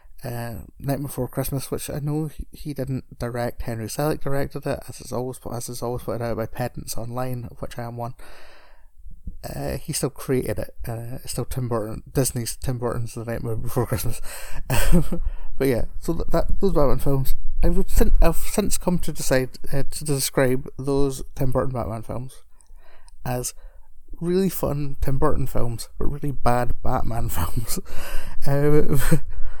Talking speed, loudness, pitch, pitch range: 165 wpm, -26 LUFS, 130 Hz, 120-140 Hz